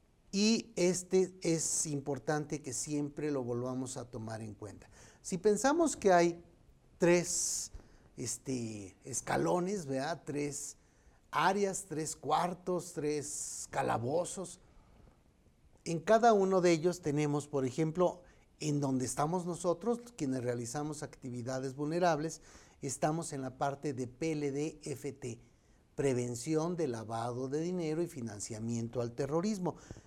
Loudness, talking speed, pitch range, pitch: -34 LUFS, 115 wpm, 130-175 Hz, 150 Hz